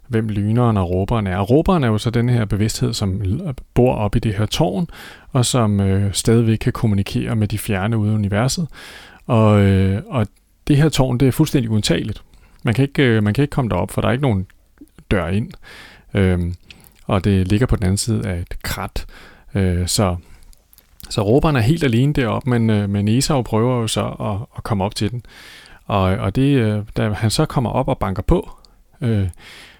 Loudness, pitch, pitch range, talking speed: -18 LUFS, 110 Hz, 100-125 Hz, 205 wpm